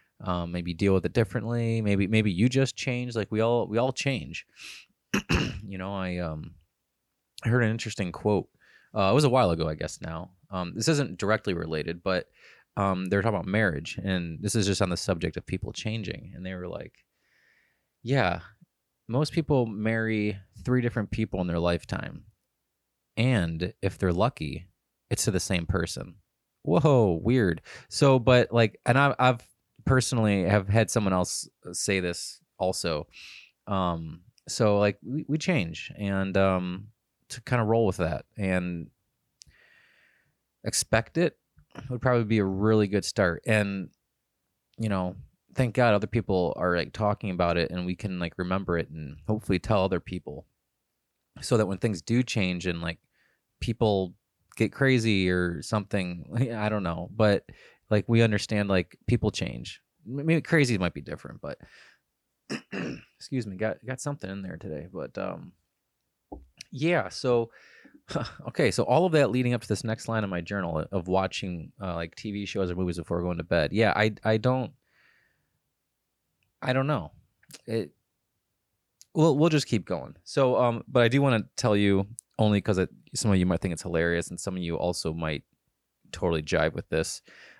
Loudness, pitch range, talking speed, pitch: -27 LUFS, 90-120 Hz, 170 wpm, 105 Hz